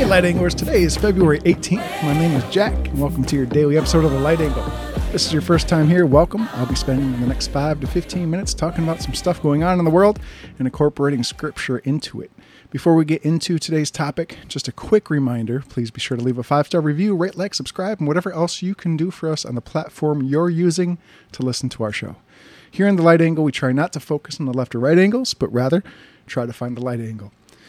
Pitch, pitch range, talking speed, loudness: 155 Hz, 130-175 Hz, 250 wpm, -19 LUFS